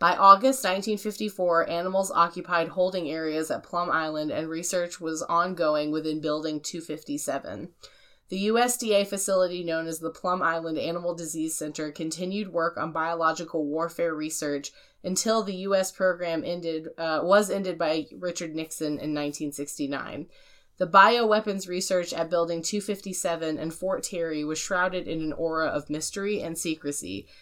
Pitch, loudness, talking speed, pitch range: 170 Hz, -27 LUFS, 140 wpm, 160-190 Hz